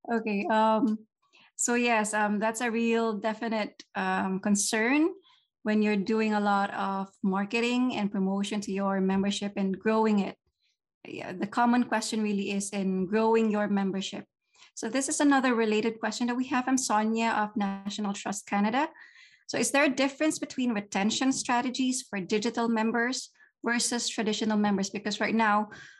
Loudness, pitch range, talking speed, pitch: -28 LUFS, 205-245 Hz, 155 wpm, 220 Hz